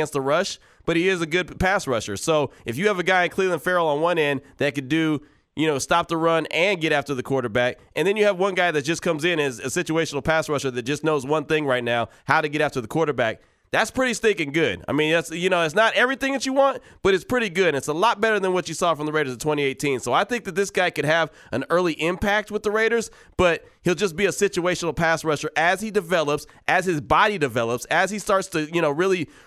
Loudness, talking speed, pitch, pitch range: -22 LUFS, 265 wpm, 165 Hz, 150-190 Hz